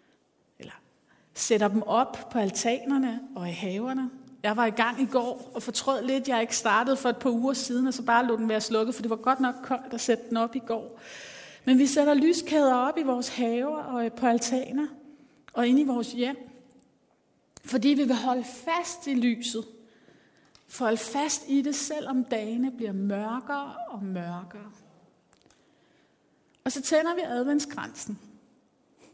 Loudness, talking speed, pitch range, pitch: -27 LUFS, 175 wpm, 230-270 Hz, 250 Hz